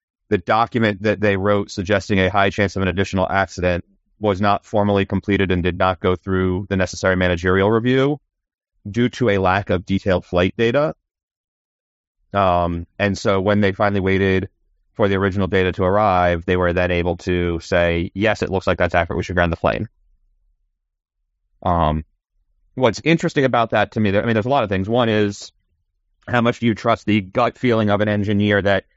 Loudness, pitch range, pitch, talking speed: -19 LUFS, 90-105 Hz, 95 Hz, 190 wpm